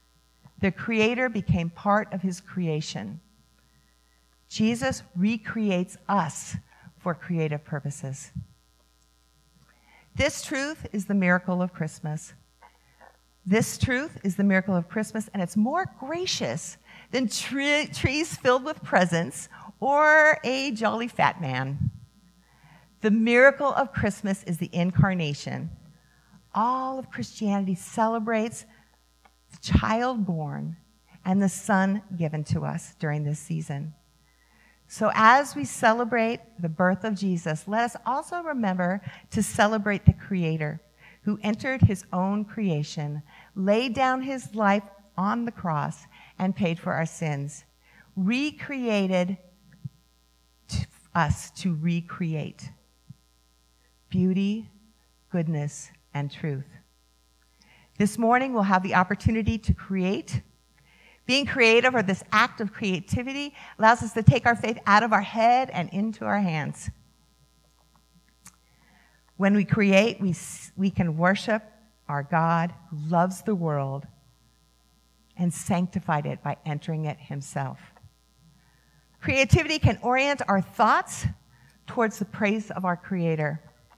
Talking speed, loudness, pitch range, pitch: 120 wpm, -25 LUFS, 150-215 Hz, 180 Hz